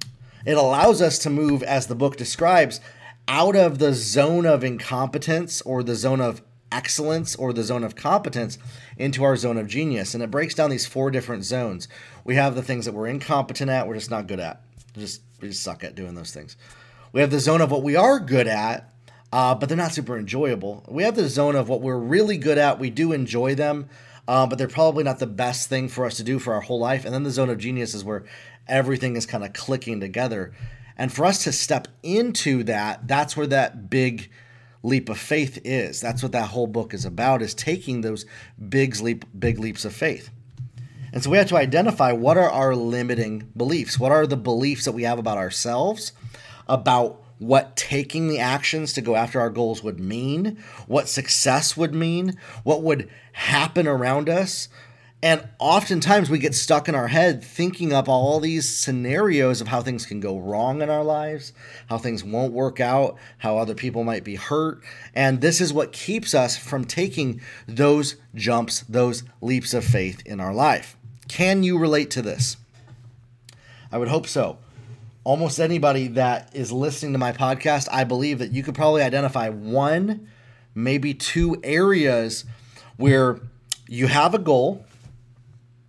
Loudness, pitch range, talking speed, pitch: -22 LUFS, 120-145 Hz, 190 wpm, 130 Hz